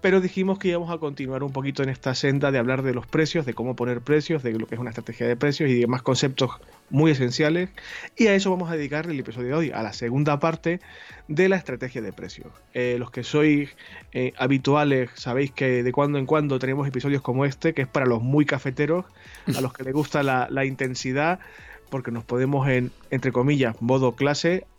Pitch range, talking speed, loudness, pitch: 125-150 Hz, 220 wpm, -24 LUFS, 135 Hz